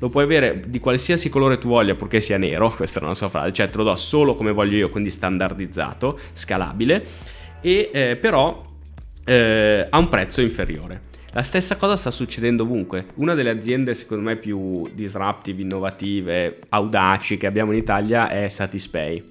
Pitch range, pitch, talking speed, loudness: 95-120 Hz, 105 Hz, 175 wpm, -20 LUFS